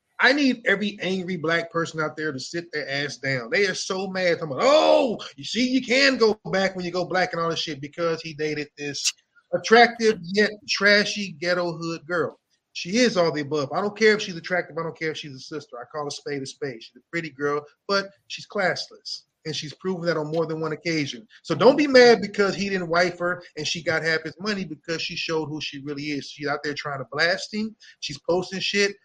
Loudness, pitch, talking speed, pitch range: -23 LUFS, 170 Hz, 240 wpm, 150-195 Hz